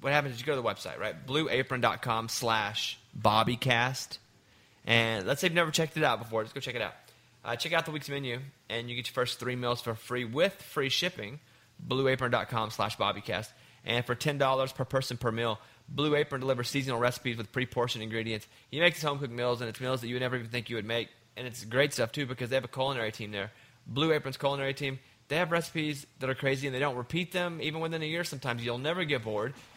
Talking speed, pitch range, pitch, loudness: 230 wpm, 115-140 Hz, 125 Hz, -31 LUFS